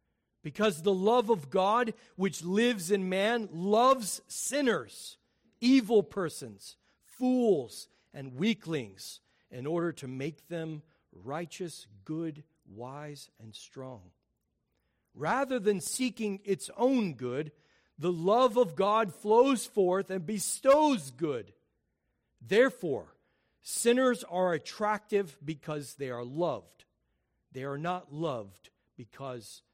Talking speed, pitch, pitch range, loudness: 110 wpm, 180 Hz, 145-220 Hz, -30 LUFS